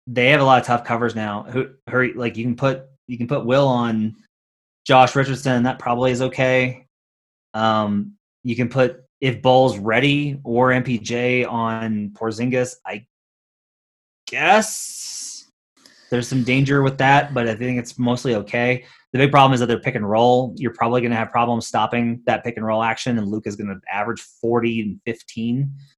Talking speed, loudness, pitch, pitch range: 180 wpm, -19 LUFS, 120 Hz, 115-130 Hz